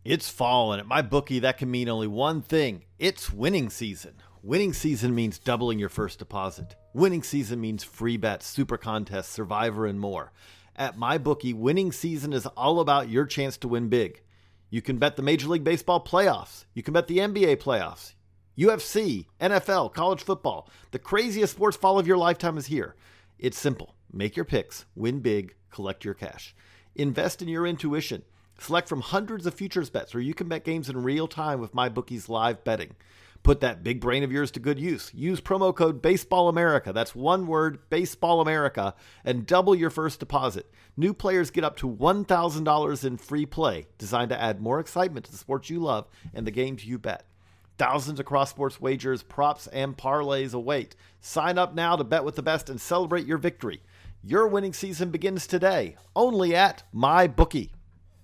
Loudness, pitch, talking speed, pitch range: -26 LUFS, 140 Hz, 185 wpm, 110-170 Hz